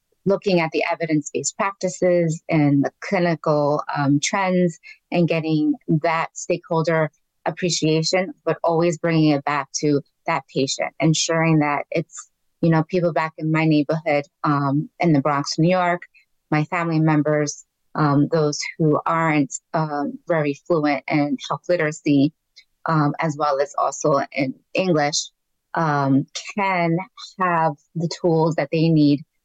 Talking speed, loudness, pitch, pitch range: 140 wpm, -21 LUFS, 160 Hz, 150-170 Hz